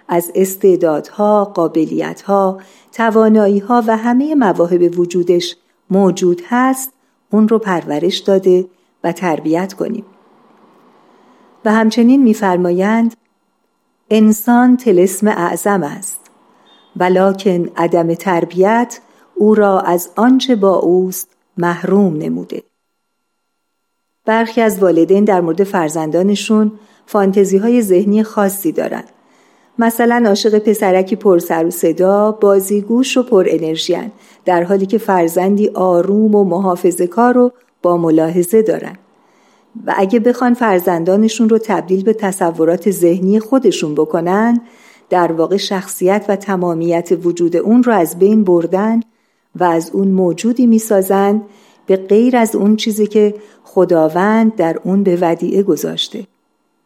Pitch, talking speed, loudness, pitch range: 195 Hz, 115 wpm, -13 LUFS, 180-220 Hz